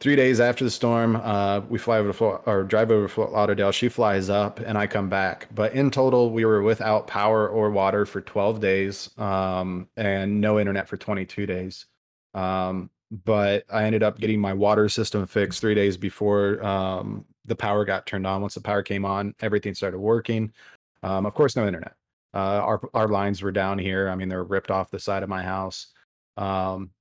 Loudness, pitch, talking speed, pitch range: -24 LUFS, 100 Hz, 210 wpm, 95-110 Hz